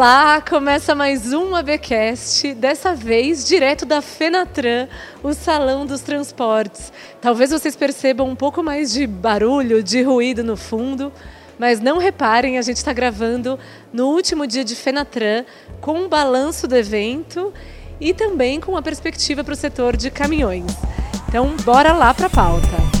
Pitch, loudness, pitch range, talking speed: 275 Hz, -17 LUFS, 245-300 Hz, 155 wpm